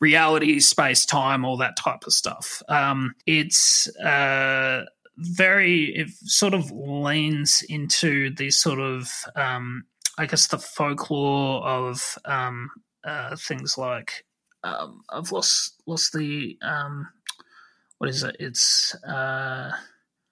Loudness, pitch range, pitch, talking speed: -21 LUFS, 135-160 Hz, 145 Hz, 120 wpm